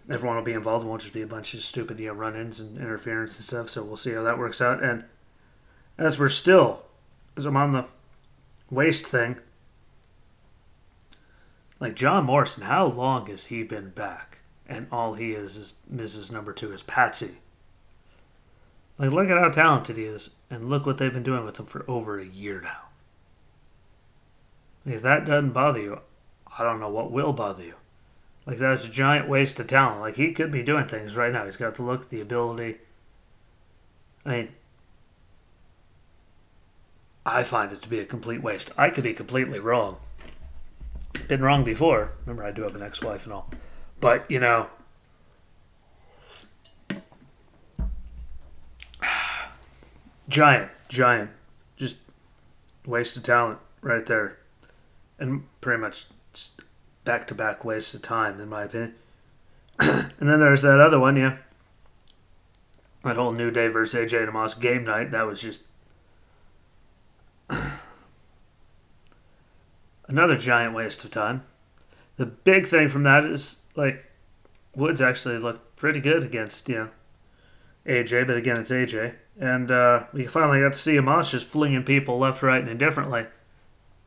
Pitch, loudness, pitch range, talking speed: 115 Hz, -24 LUFS, 105-130 Hz, 155 wpm